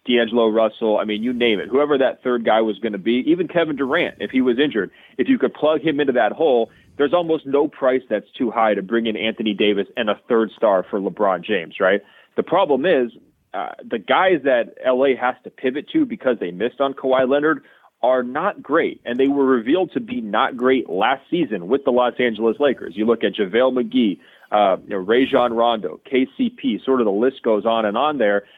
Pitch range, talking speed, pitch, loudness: 115-140 Hz, 225 wpm, 125 Hz, -19 LUFS